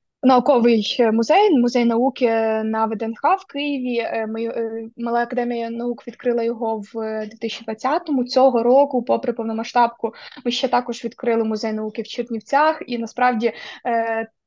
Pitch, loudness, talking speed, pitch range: 235 Hz, -20 LUFS, 120 wpm, 225-250 Hz